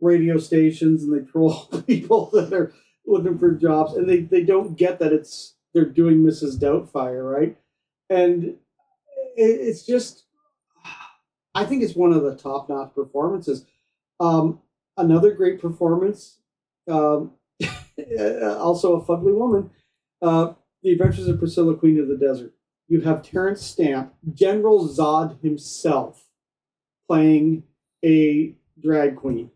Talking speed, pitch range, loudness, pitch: 130 wpm, 155-190 Hz, -20 LUFS, 165 Hz